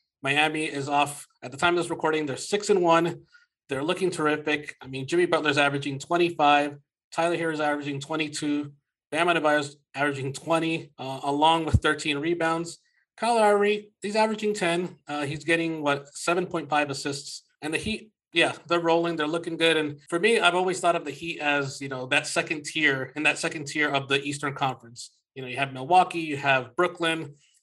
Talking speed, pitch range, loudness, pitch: 190 wpm, 145-170 Hz, -25 LUFS, 155 Hz